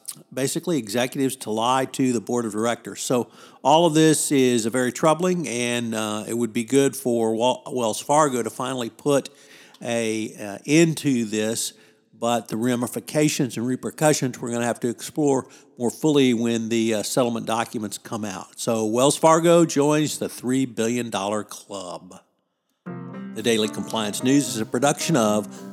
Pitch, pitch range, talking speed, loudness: 120 Hz, 115-140 Hz, 165 wpm, -22 LUFS